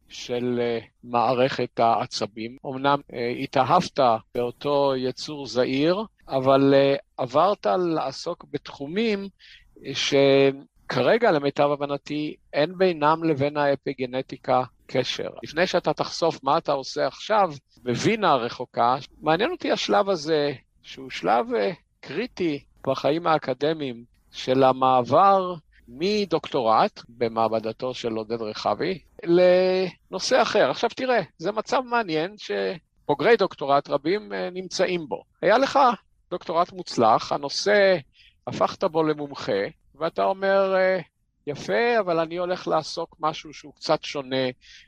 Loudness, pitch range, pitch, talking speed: -24 LUFS, 130-180 Hz, 145 Hz, 105 wpm